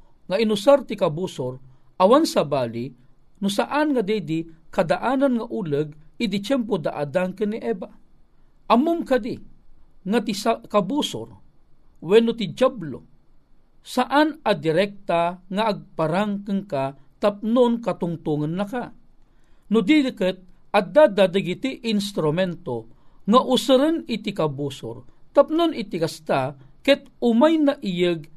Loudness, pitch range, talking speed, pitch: -22 LUFS, 165-250 Hz, 115 wpm, 205 Hz